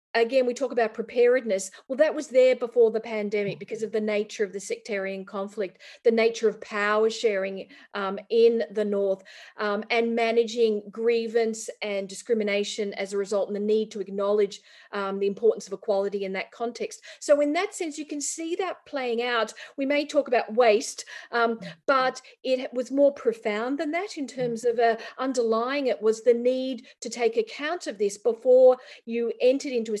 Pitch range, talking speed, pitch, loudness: 210-260 Hz, 185 wpm, 230 Hz, -26 LUFS